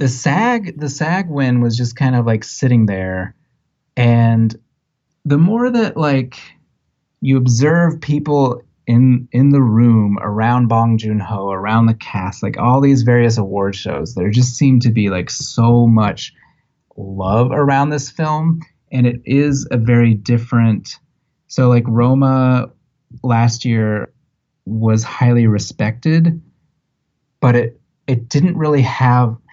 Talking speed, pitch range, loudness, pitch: 140 wpm, 115-145 Hz, -15 LUFS, 125 Hz